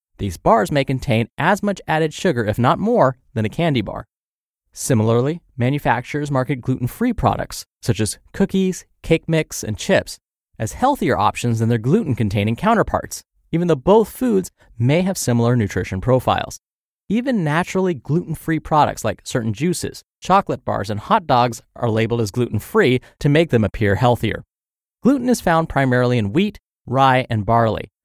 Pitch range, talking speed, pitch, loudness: 115-170 Hz, 165 wpm, 130 Hz, -19 LUFS